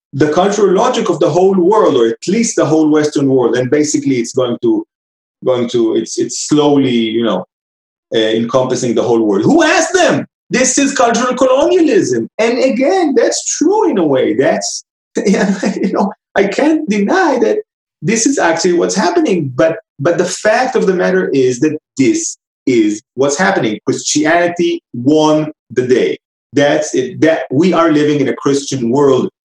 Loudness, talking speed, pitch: -13 LUFS, 170 wpm, 185 Hz